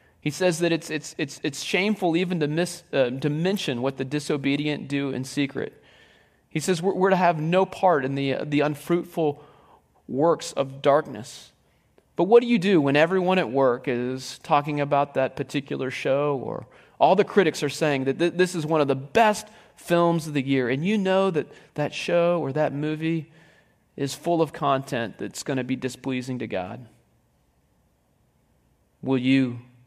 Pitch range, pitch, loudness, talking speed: 135-170 Hz, 150 Hz, -24 LUFS, 185 wpm